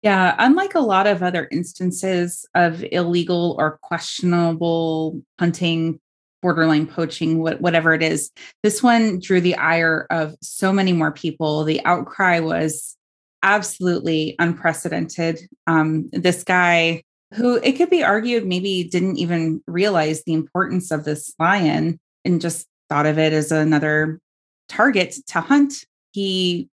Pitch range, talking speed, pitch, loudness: 160-185 Hz, 135 wpm, 170 Hz, -19 LUFS